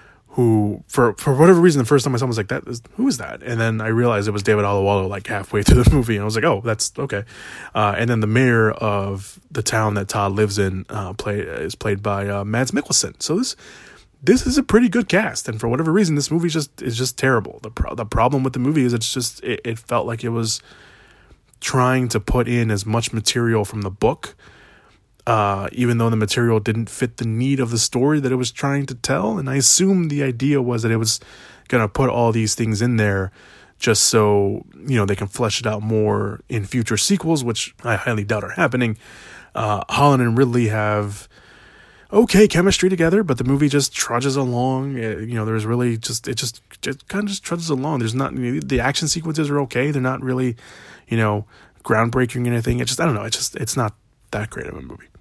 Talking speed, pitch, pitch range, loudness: 235 wpm, 120 Hz, 110-135 Hz, -19 LUFS